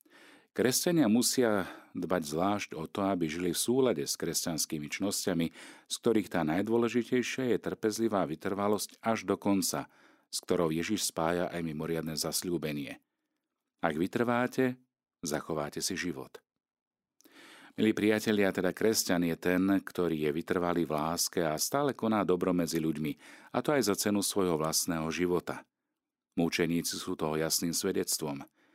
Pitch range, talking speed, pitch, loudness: 80-110 Hz, 135 wpm, 90 Hz, -31 LUFS